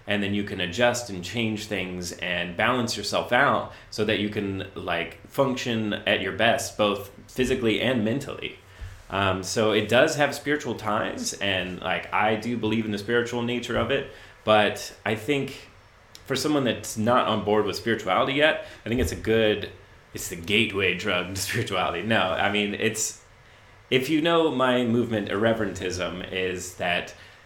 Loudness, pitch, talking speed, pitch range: -25 LUFS, 105 Hz, 170 wpm, 95-120 Hz